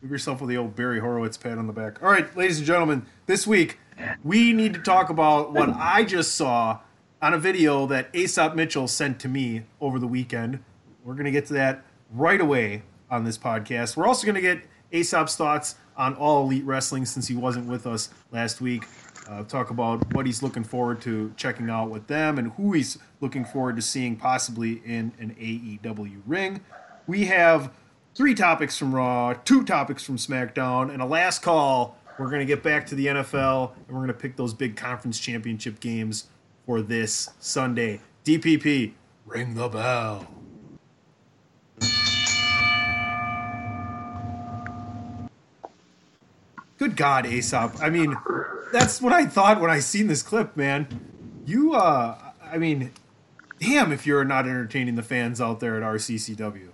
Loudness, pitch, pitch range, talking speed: -24 LUFS, 130 Hz, 115-150 Hz, 170 wpm